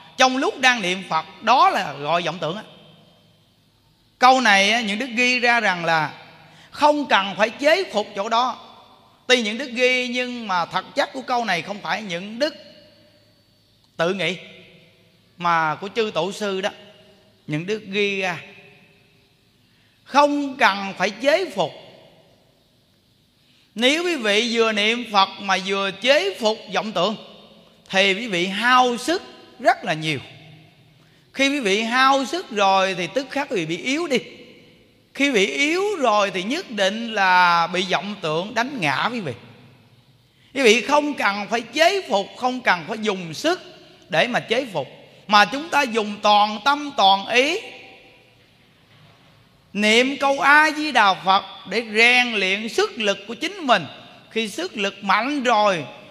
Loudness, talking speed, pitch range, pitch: -20 LUFS, 160 wpm, 175-250 Hz, 205 Hz